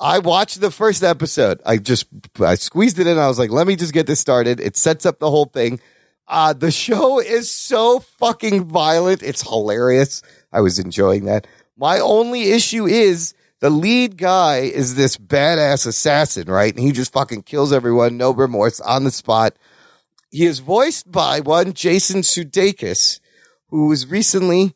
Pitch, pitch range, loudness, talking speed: 160 Hz, 130-190 Hz, -16 LUFS, 175 wpm